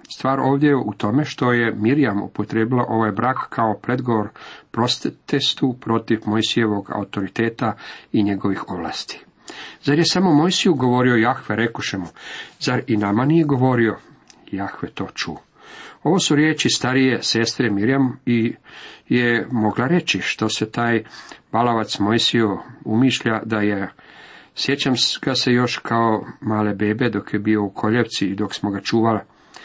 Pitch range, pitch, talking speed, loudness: 110-130 Hz, 115 Hz, 145 wpm, -20 LUFS